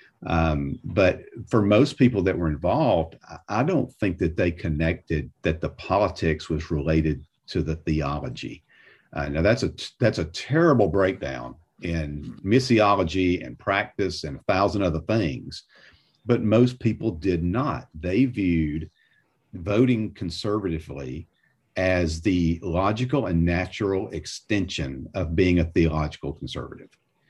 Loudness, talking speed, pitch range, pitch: -24 LUFS, 130 wpm, 80-105 Hz, 90 Hz